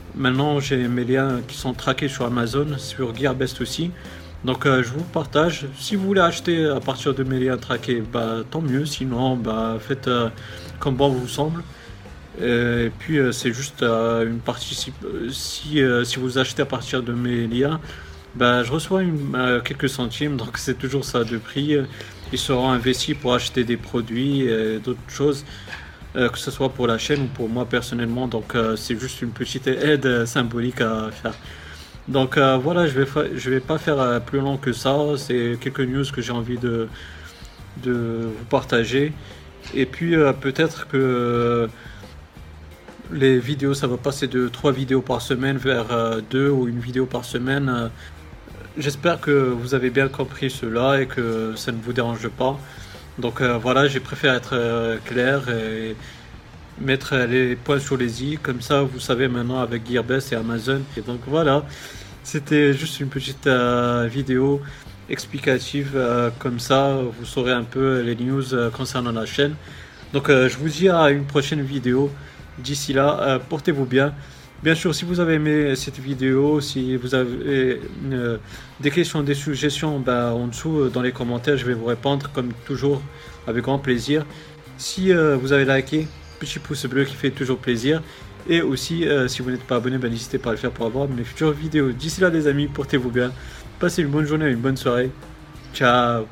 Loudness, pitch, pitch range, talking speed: -22 LUFS, 130 Hz, 120-140 Hz, 185 wpm